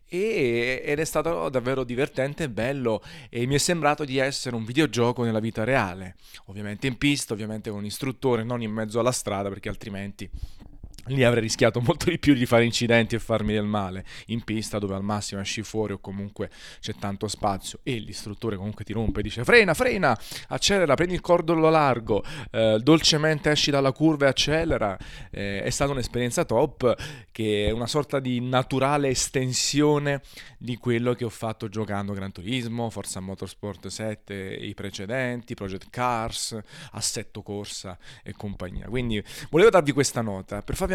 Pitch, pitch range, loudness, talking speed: 115 Hz, 105-135 Hz, -25 LUFS, 170 wpm